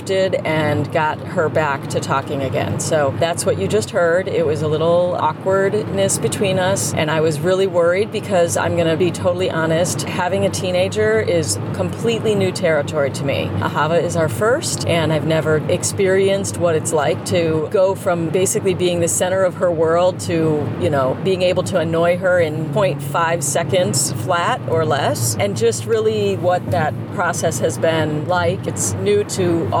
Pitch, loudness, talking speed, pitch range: 165 Hz, -18 LUFS, 175 wpm, 145-180 Hz